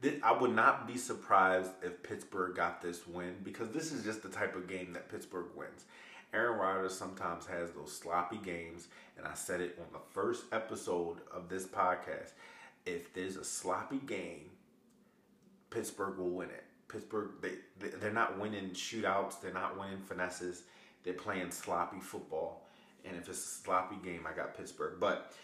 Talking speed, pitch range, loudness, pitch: 165 wpm, 90-100 Hz, -38 LUFS, 95 Hz